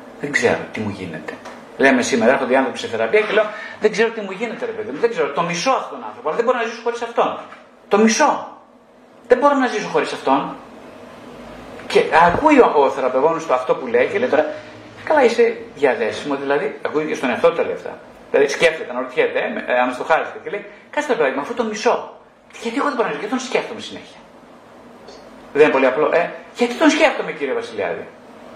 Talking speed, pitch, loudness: 210 wpm, 255 Hz, -18 LUFS